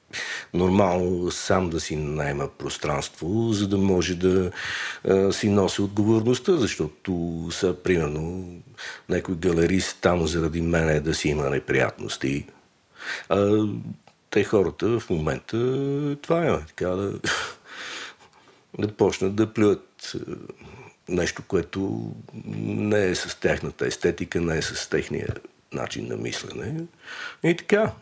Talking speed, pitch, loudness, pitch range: 120 wpm, 95 Hz, -25 LUFS, 85-110 Hz